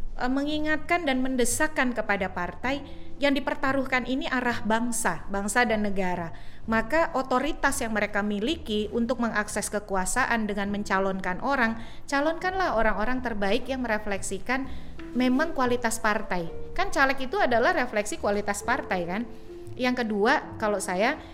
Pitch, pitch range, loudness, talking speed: 235 Hz, 205-265 Hz, -27 LUFS, 125 wpm